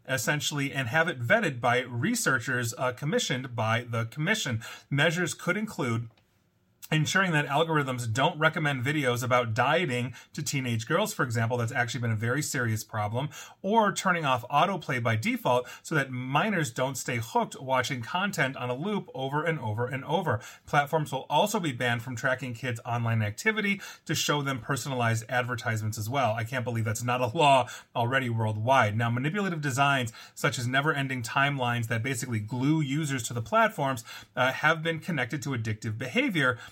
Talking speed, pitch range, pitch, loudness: 170 wpm, 120-155 Hz, 130 Hz, -28 LUFS